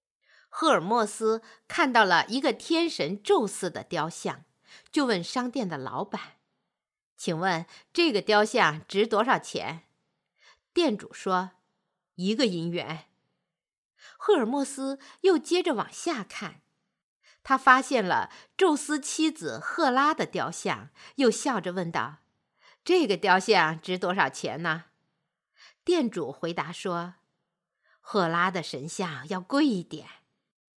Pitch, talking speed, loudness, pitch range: 210 Hz, 175 characters per minute, -27 LUFS, 175-280 Hz